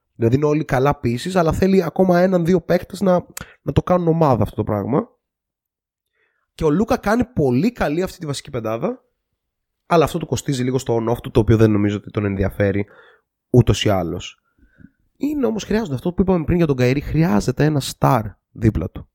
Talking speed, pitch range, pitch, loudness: 190 wpm, 115-180 Hz, 145 Hz, -19 LUFS